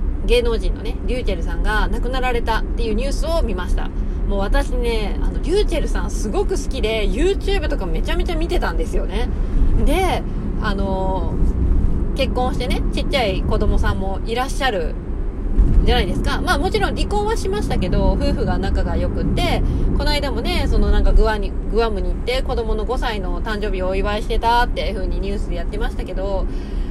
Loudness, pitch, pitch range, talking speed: -21 LUFS, 230 Hz, 210-265 Hz, 415 characters per minute